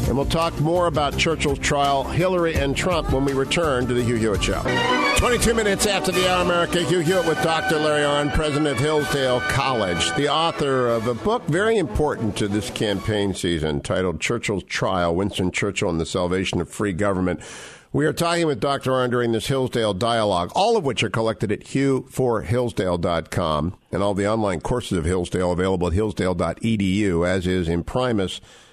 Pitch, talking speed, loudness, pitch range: 120 Hz, 190 wpm, -21 LUFS, 95-145 Hz